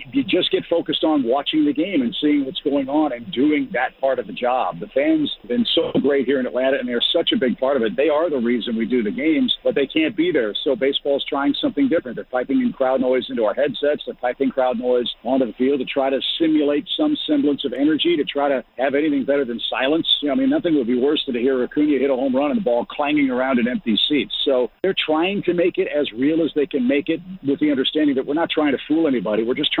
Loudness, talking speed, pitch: -20 LUFS, 275 wpm, 150 Hz